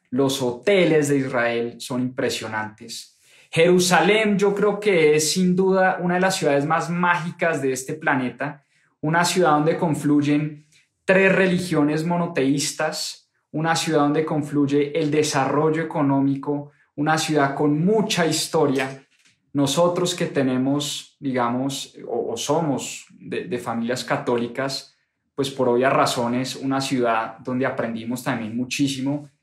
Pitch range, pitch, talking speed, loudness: 135-165 Hz, 145 Hz, 125 wpm, -21 LUFS